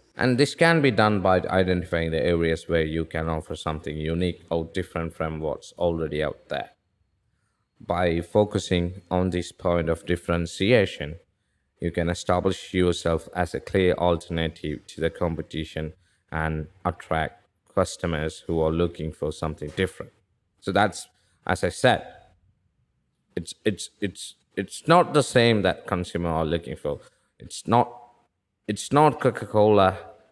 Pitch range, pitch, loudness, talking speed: 80-95 Hz, 85 Hz, -25 LUFS, 140 wpm